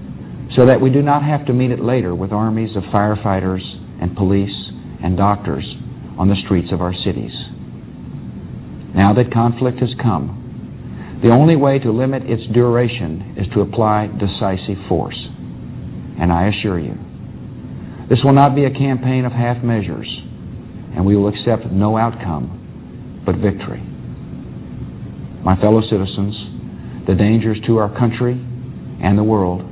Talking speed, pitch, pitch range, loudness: 145 wpm, 105 Hz, 95-120 Hz, -16 LUFS